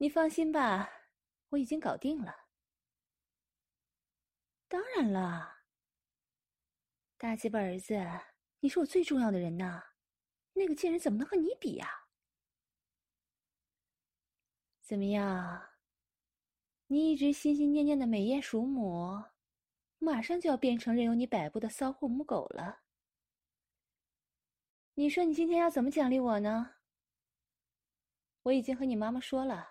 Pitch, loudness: 225 Hz, -33 LUFS